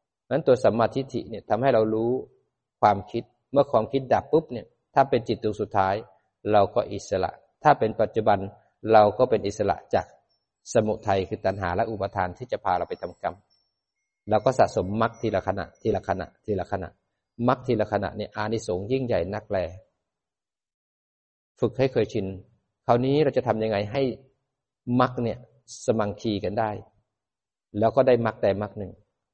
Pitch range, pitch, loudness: 100-120 Hz, 110 Hz, -25 LUFS